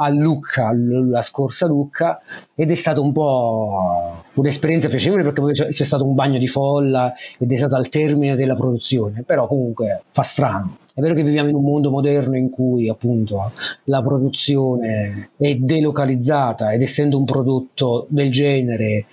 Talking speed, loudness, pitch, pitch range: 165 wpm, -18 LUFS, 135 Hz, 125-145 Hz